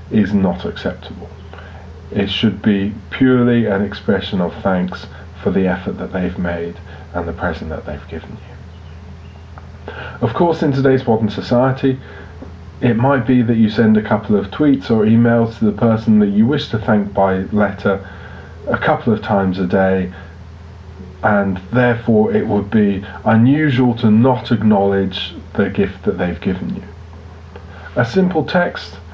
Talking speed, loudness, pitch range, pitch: 155 wpm, -16 LUFS, 85-115 Hz, 100 Hz